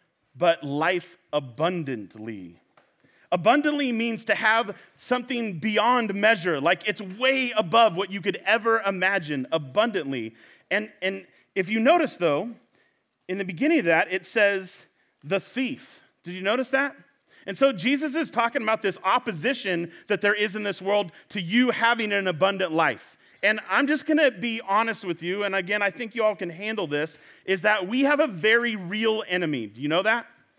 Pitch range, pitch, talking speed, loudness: 180-235 Hz, 205 Hz, 175 wpm, -24 LUFS